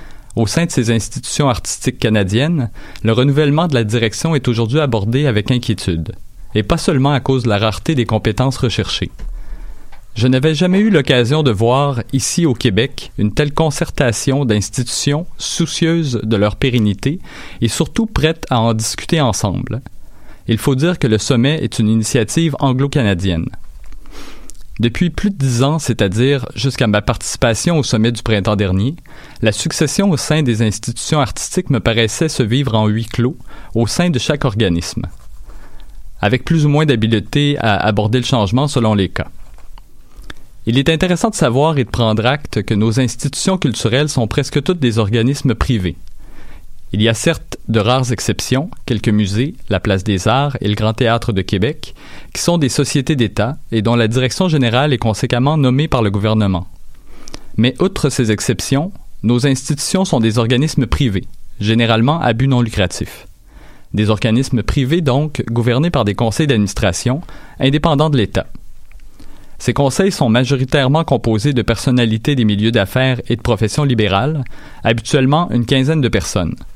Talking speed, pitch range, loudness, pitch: 165 wpm, 110-145 Hz, -15 LUFS, 125 Hz